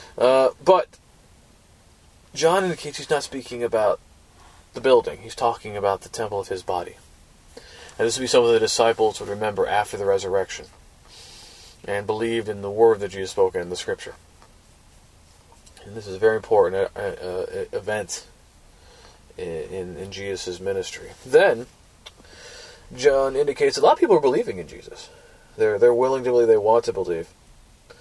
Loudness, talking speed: -22 LUFS, 160 wpm